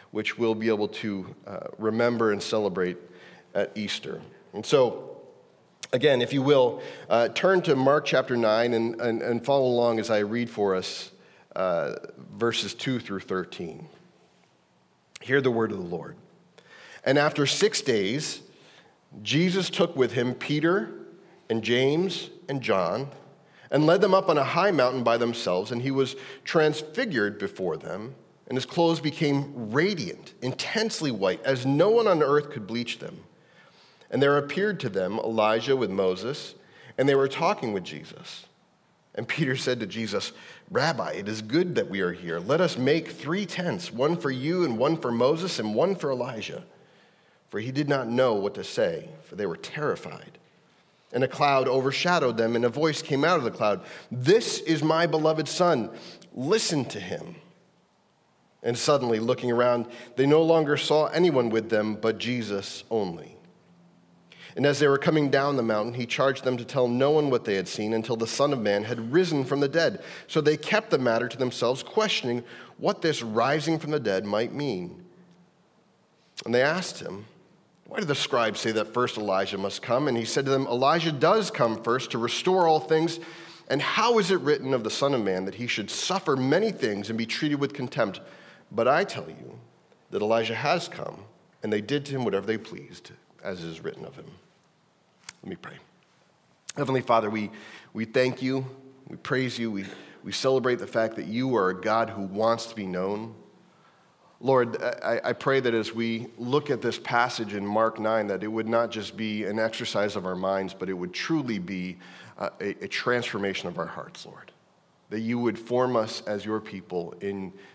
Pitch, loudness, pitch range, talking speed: 125 Hz, -26 LUFS, 110-150 Hz, 185 wpm